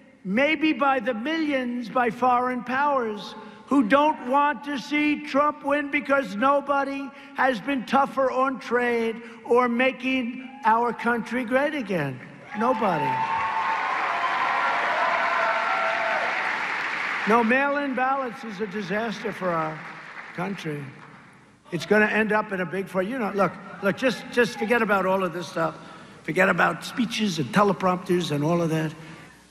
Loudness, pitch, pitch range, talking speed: -24 LUFS, 235 Hz, 190-265 Hz, 135 wpm